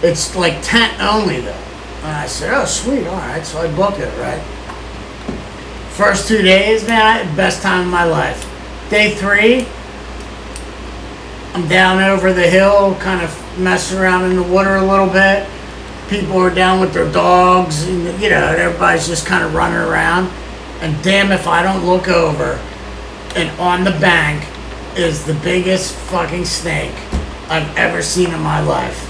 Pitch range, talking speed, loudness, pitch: 170-195 Hz, 165 wpm, -14 LUFS, 185 Hz